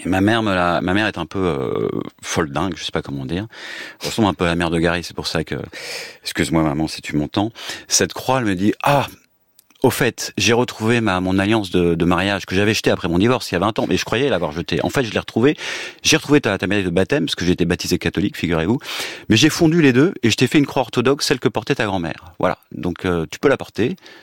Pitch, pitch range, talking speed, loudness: 100 Hz, 85-115 Hz, 270 wpm, -19 LUFS